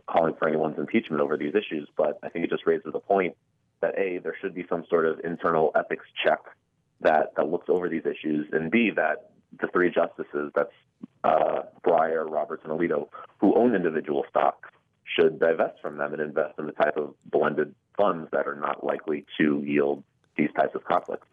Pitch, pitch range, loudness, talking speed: 75 Hz, 75-90 Hz, -26 LUFS, 195 wpm